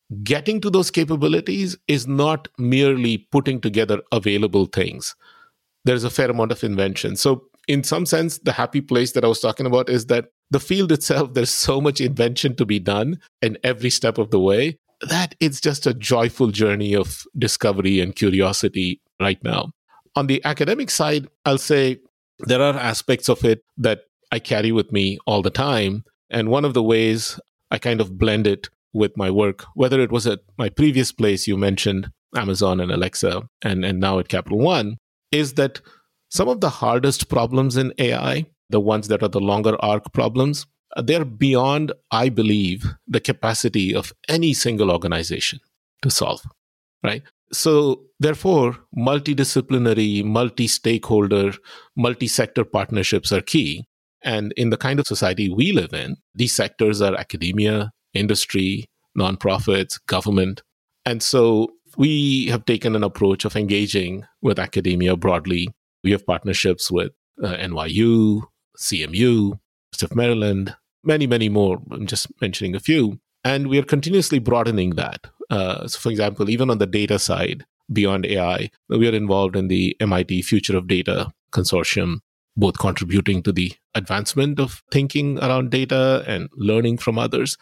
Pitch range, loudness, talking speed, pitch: 100-135 Hz, -20 LUFS, 160 wpm, 115 Hz